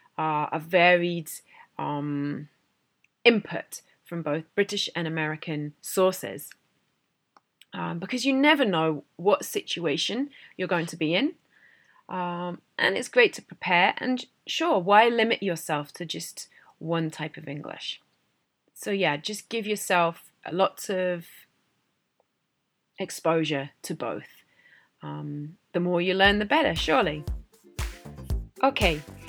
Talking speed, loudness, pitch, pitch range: 120 wpm, -26 LUFS, 175 Hz, 155-210 Hz